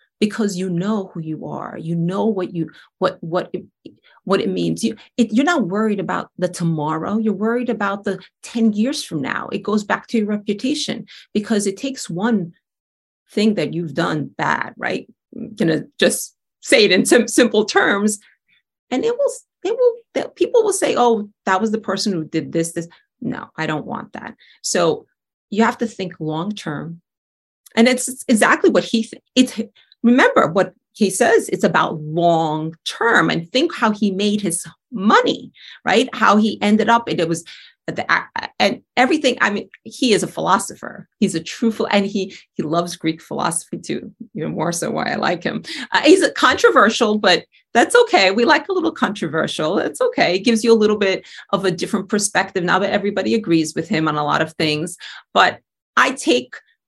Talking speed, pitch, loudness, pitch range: 190 wpm, 210 Hz, -18 LUFS, 175-235 Hz